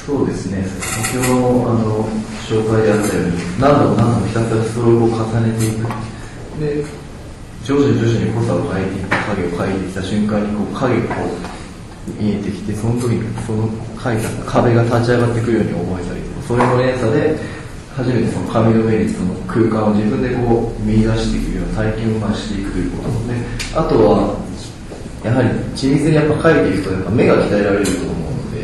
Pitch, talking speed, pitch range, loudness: 110 Hz, 375 characters per minute, 105-120 Hz, -17 LUFS